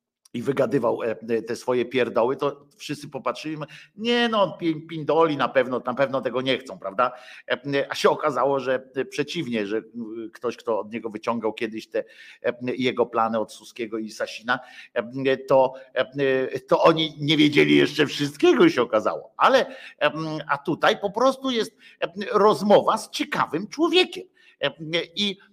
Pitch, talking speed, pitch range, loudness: 140 Hz, 140 wpm, 125-180 Hz, -23 LUFS